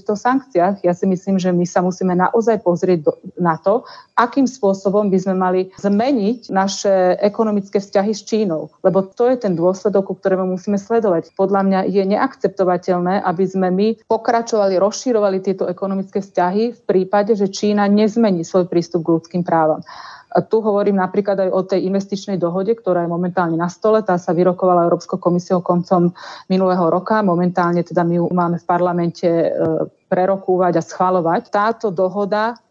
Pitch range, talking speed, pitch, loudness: 180-205 Hz, 165 wpm, 190 Hz, -17 LUFS